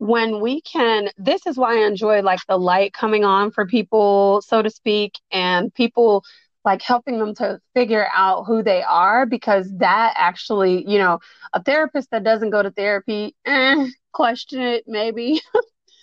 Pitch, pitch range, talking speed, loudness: 220 Hz, 200-245 Hz, 170 wpm, -18 LUFS